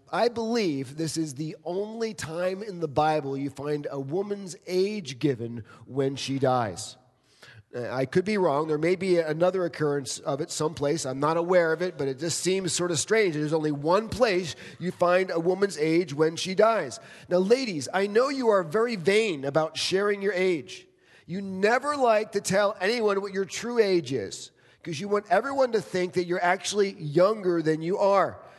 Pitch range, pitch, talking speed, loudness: 150-200 Hz, 180 Hz, 190 wpm, -26 LUFS